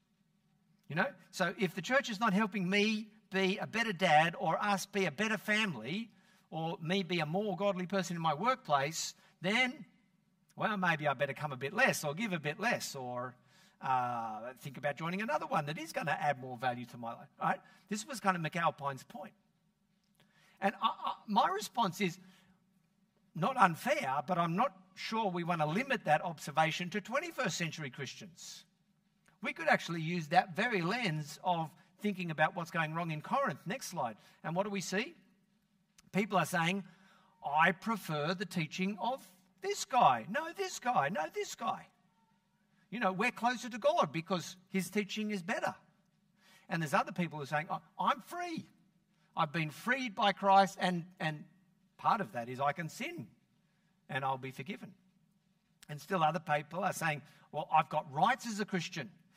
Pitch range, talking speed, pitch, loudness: 170-195 Hz, 185 wpm, 190 Hz, -34 LUFS